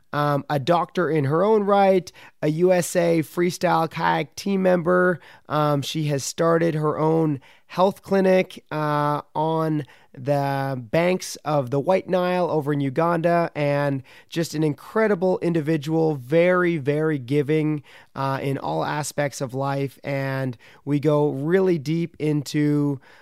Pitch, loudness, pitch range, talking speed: 155 Hz, -22 LUFS, 145-175 Hz, 135 wpm